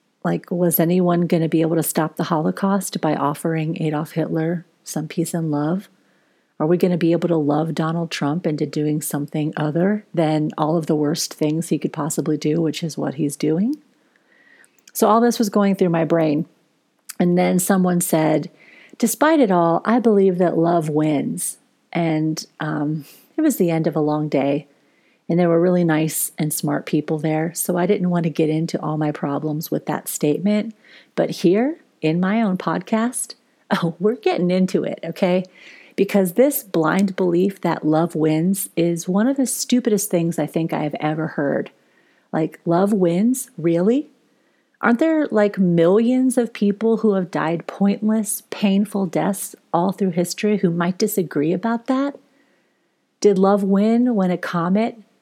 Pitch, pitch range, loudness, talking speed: 175 Hz, 160-210 Hz, -20 LUFS, 175 wpm